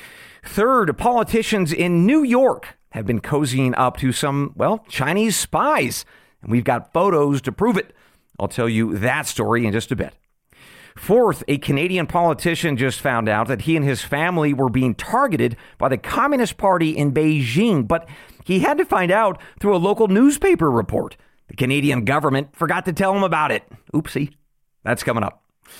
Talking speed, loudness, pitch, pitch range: 175 wpm, -19 LUFS, 150 Hz, 130-195 Hz